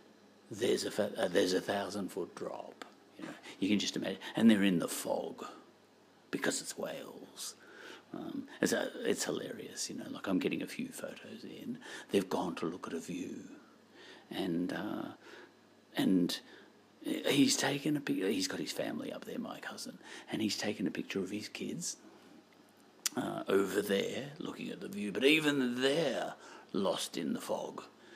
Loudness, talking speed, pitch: -35 LUFS, 170 wpm, 155 Hz